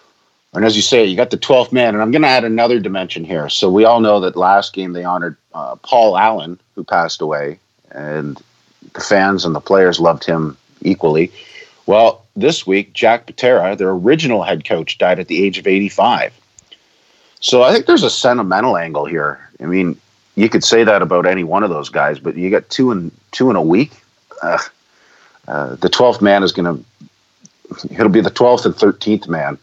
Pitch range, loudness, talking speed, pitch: 85-110 Hz, -14 LUFS, 205 wpm, 95 Hz